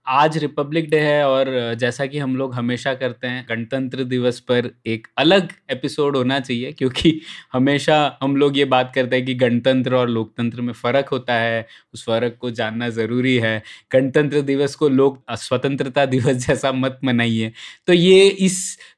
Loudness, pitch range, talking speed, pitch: -19 LUFS, 120-145 Hz, 170 wpm, 130 Hz